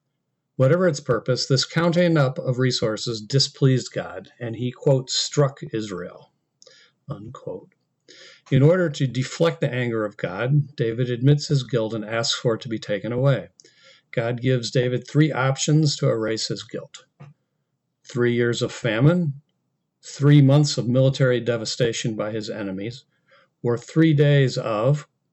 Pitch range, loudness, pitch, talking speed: 120-150 Hz, -22 LUFS, 135 Hz, 145 wpm